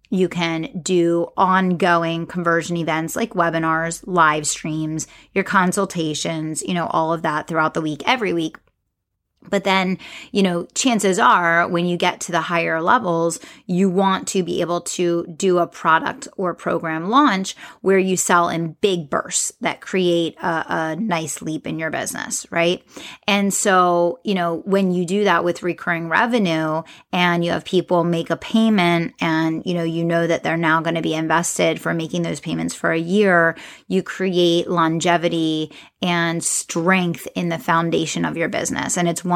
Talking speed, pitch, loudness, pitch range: 175 wpm, 170 Hz, -19 LUFS, 165-185 Hz